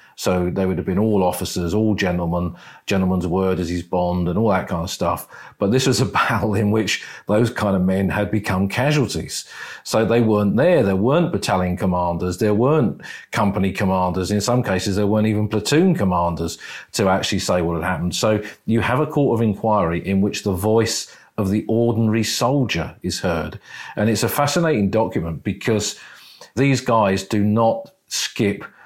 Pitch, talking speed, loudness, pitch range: 105 Hz, 185 wpm, -20 LUFS, 90-110 Hz